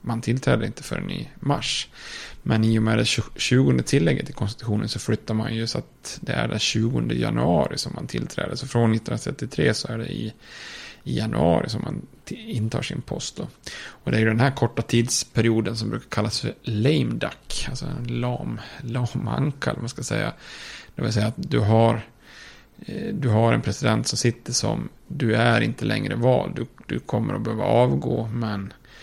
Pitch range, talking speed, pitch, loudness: 110-125 Hz, 185 wpm, 115 Hz, -24 LUFS